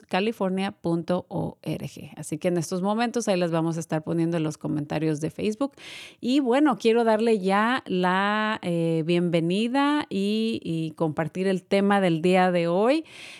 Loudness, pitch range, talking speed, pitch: -25 LUFS, 165-220 Hz, 150 wpm, 185 Hz